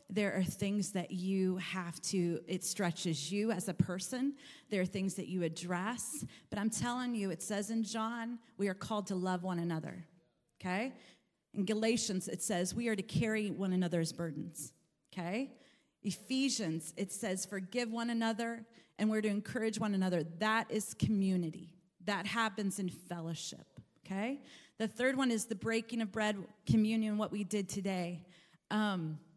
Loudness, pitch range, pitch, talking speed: -37 LUFS, 180-225 Hz, 200 Hz, 165 wpm